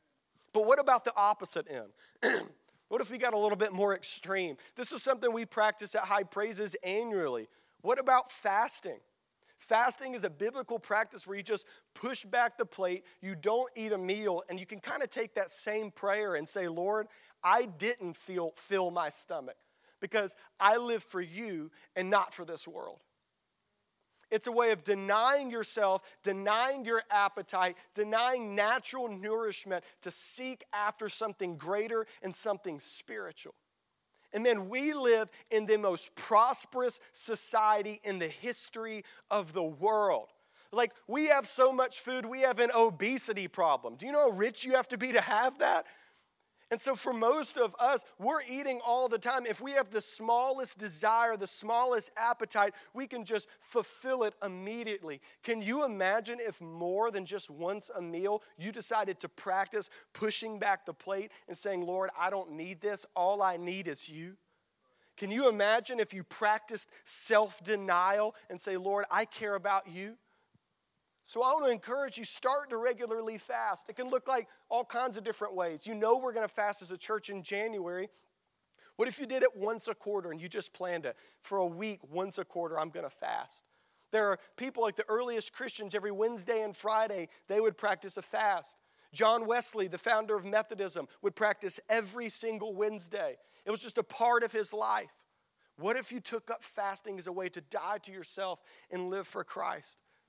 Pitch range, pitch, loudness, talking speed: 195-235 Hz, 215 Hz, -33 LUFS, 180 wpm